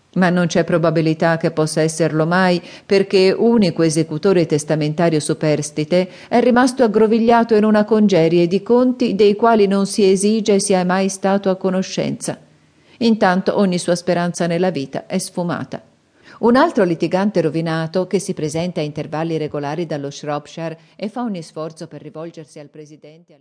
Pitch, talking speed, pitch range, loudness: 175 Hz, 155 wpm, 160-195 Hz, -17 LUFS